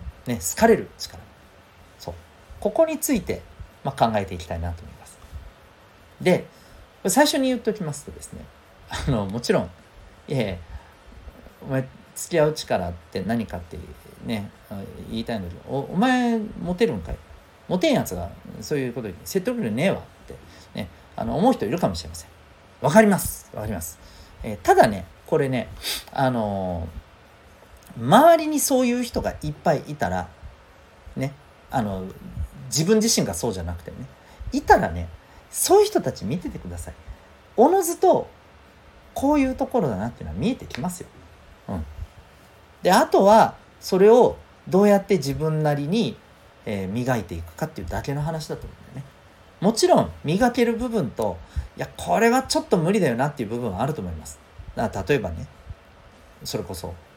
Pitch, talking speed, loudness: 110 Hz, 320 characters per minute, -22 LUFS